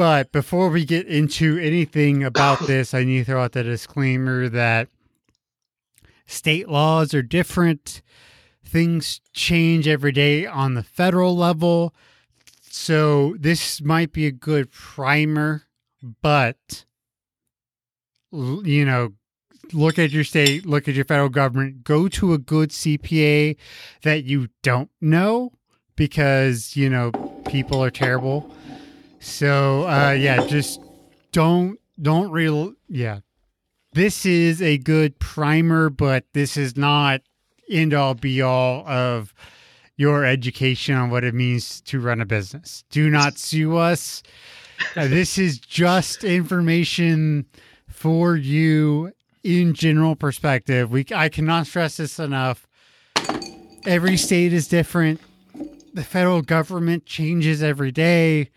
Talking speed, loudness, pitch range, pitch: 125 wpm, -20 LUFS, 130-165 Hz, 150 Hz